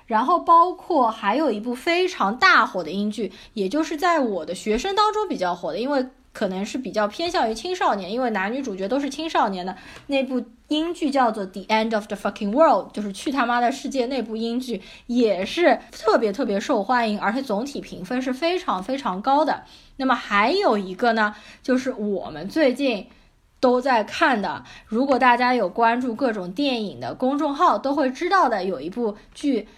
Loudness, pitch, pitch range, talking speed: -22 LUFS, 245 Hz, 210-280 Hz, 320 characters per minute